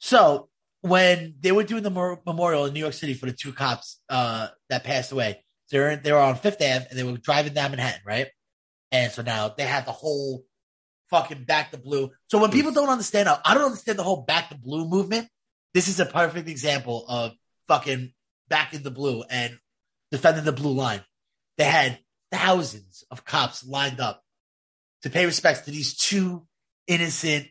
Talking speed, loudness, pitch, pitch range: 190 wpm, -24 LUFS, 145 Hz, 125-175 Hz